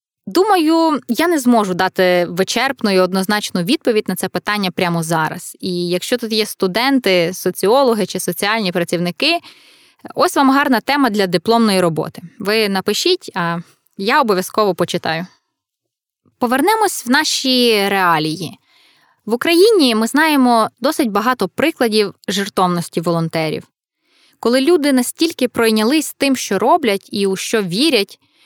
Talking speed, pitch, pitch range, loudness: 125 wpm, 215 Hz, 185-275 Hz, -16 LUFS